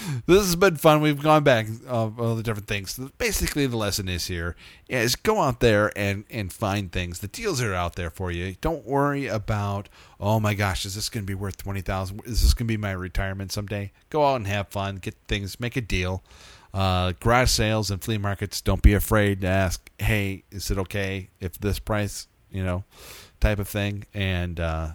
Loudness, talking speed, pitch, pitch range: -25 LUFS, 210 wpm, 100 Hz, 95-115 Hz